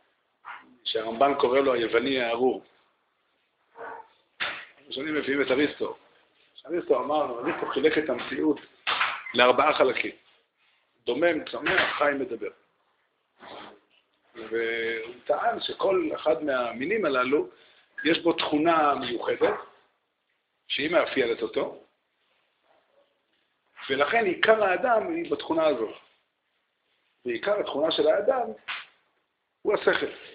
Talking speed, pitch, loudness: 90 wpm, 360 Hz, -26 LUFS